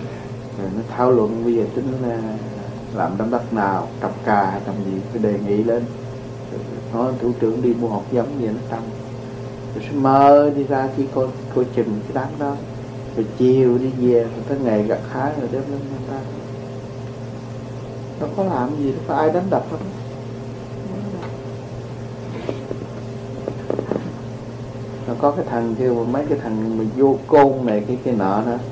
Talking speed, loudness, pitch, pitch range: 170 wpm, -21 LUFS, 125 Hz, 115-130 Hz